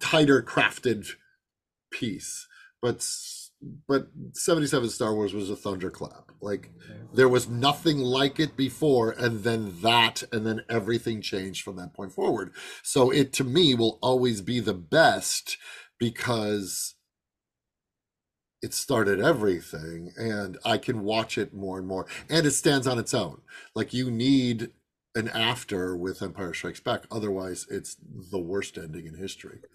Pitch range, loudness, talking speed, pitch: 100-135 Hz, -26 LUFS, 145 wpm, 115 Hz